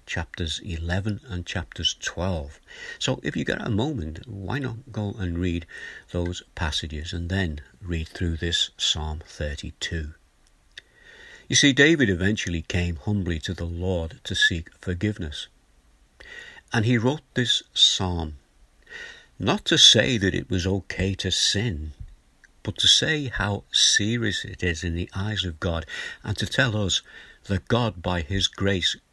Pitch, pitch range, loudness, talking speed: 90 Hz, 85-105 Hz, -24 LUFS, 150 wpm